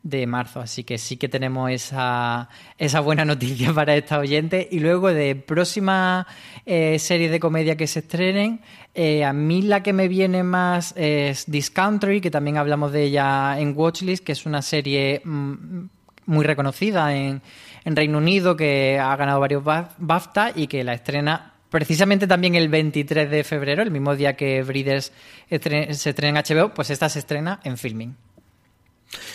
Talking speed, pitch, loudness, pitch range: 170 wpm, 150 Hz, -21 LUFS, 140-170 Hz